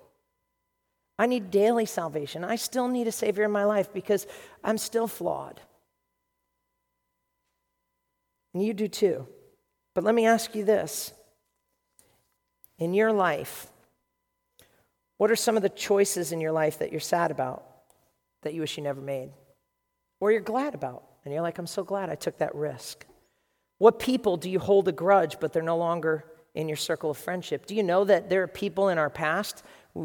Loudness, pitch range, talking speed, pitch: -27 LUFS, 155-220 Hz, 175 wpm, 190 Hz